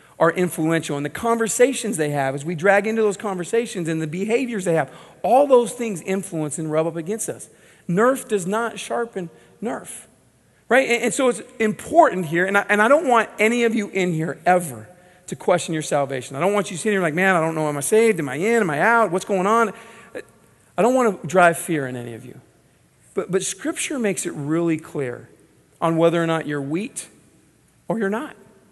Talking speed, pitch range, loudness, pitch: 215 wpm, 165-225 Hz, -21 LUFS, 185 Hz